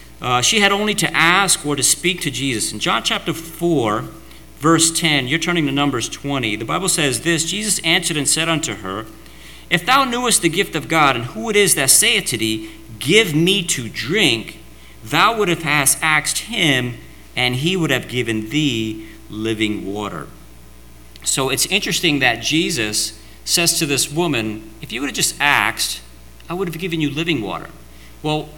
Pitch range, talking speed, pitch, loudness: 110-170 Hz, 180 wpm, 150 Hz, -17 LUFS